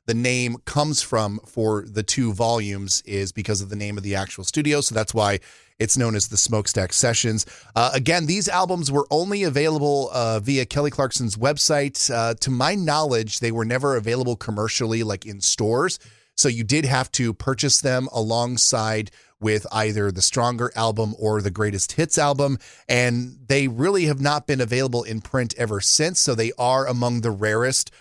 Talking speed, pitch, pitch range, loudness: 180 wpm, 120 Hz, 110-135 Hz, -21 LUFS